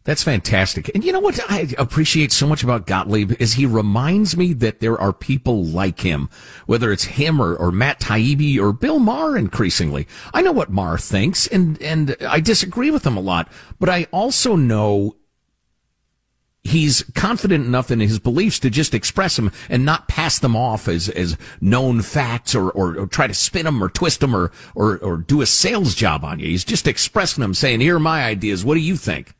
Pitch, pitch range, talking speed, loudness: 125 Hz, 105-160 Hz, 205 wpm, -18 LUFS